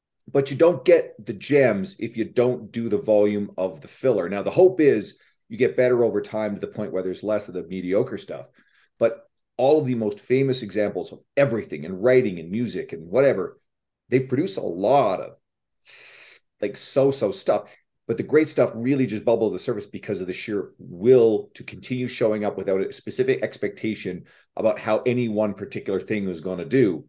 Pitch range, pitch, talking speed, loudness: 105-135 Hz, 115 Hz, 200 wpm, -23 LUFS